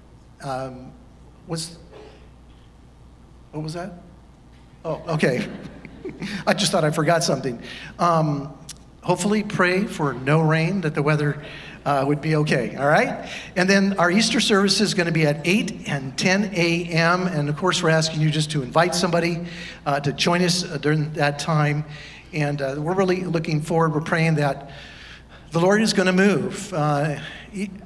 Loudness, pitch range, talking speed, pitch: -21 LUFS, 145-180 Hz, 165 wpm, 160 Hz